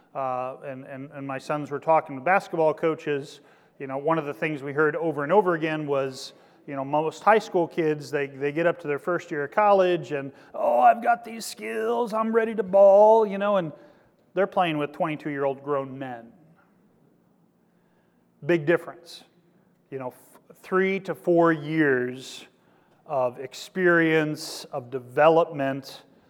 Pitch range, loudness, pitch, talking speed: 140-185 Hz, -24 LUFS, 160 Hz, 165 wpm